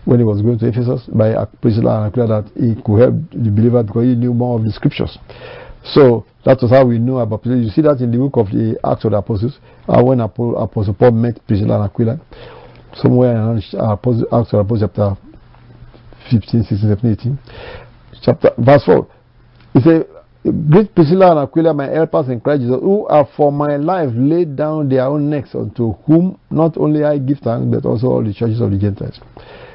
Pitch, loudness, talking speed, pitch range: 120 Hz, -14 LUFS, 195 wpm, 110-145 Hz